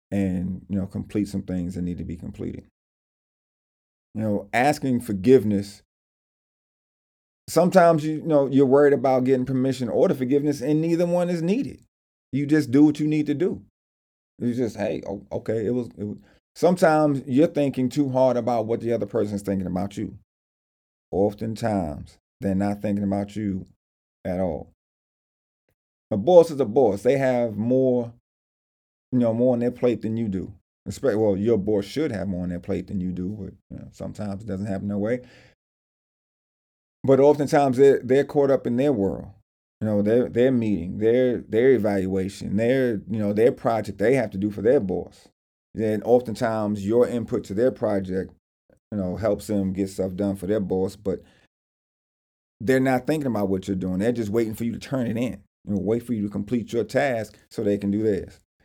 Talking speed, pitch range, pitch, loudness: 190 wpm, 95-125 Hz, 105 Hz, -23 LUFS